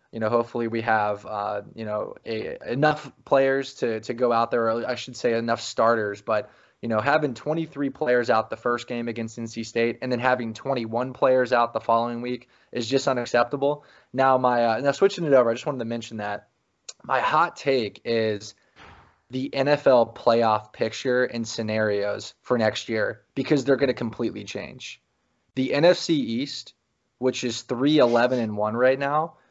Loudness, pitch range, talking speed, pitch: -24 LUFS, 115-135 Hz, 185 wpm, 120 Hz